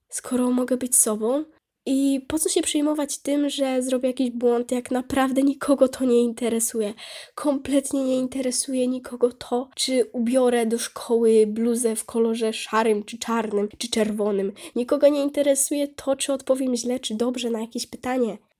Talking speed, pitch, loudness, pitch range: 160 wpm, 250 Hz, -23 LUFS, 235-275 Hz